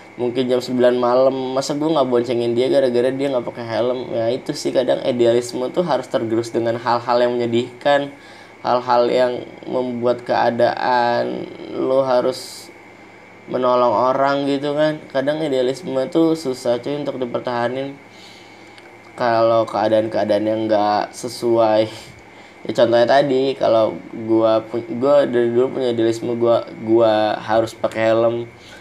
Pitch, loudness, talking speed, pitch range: 120 Hz, -18 LUFS, 130 wpm, 115-130 Hz